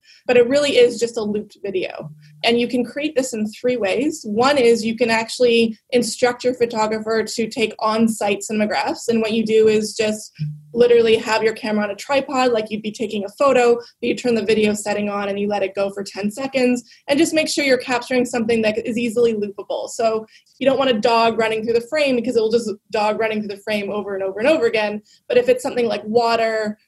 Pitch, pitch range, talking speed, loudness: 225 Hz, 215-245 Hz, 235 wpm, -19 LUFS